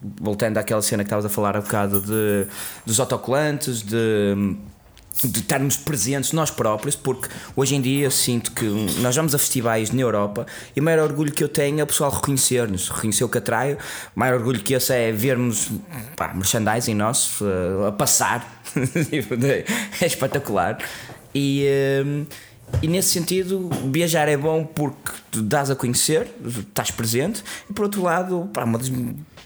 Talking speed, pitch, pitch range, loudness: 170 wpm, 130 Hz, 110-145 Hz, -21 LUFS